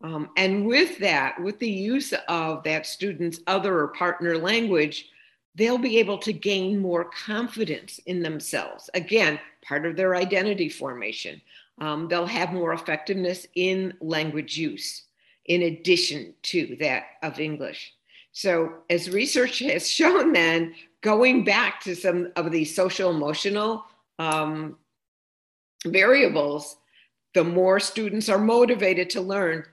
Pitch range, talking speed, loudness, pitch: 160-210 Hz, 135 wpm, -24 LUFS, 180 Hz